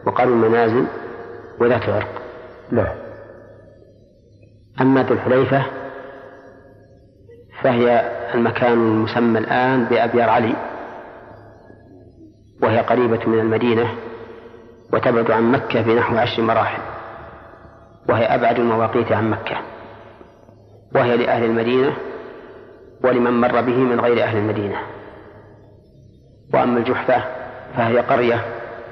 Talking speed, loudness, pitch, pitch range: 85 wpm, -18 LUFS, 115 Hz, 110-125 Hz